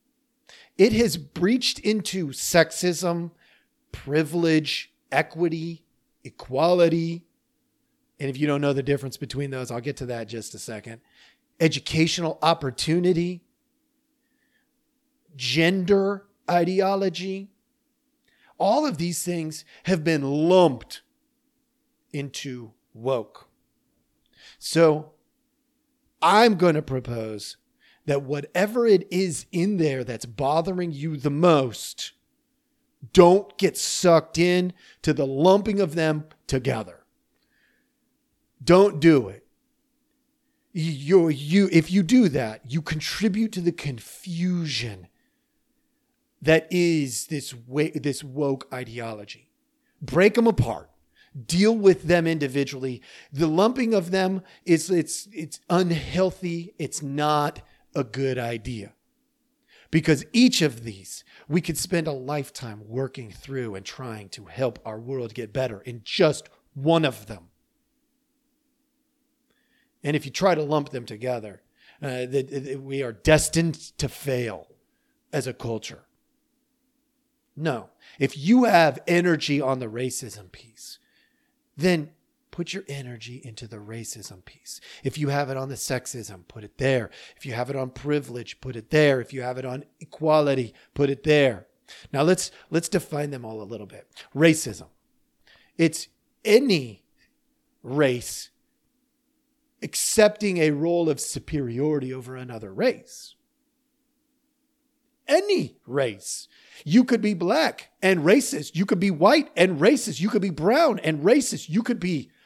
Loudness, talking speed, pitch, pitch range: -23 LUFS, 125 wpm, 165 Hz, 135-210 Hz